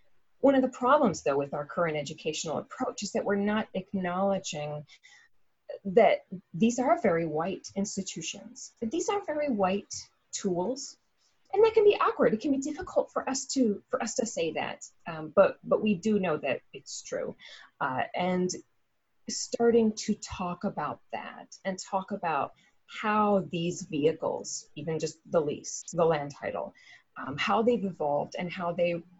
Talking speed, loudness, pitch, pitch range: 165 wpm, -29 LUFS, 195 Hz, 170-255 Hz